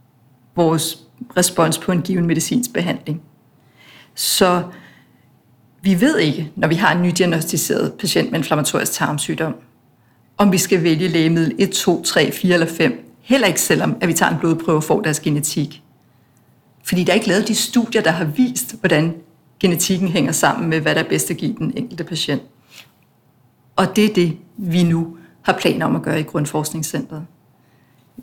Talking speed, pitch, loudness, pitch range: 170 wpm, 165 Hz, -18 LUFS, 150-185 Hz